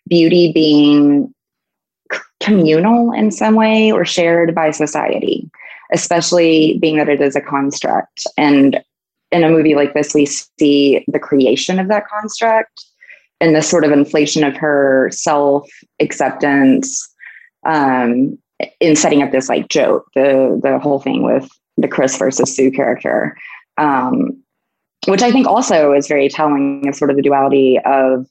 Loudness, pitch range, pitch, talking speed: -13 LUFS, 140-175 Hz, 150 Hz, 150 wpm